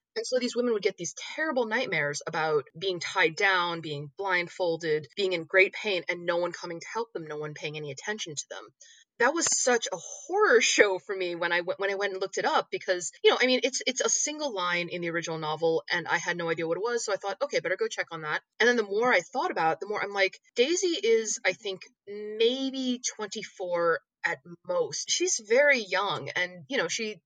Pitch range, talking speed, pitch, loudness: 170-240 Hz, 240 wpm, 195 Hz, -27 LUFS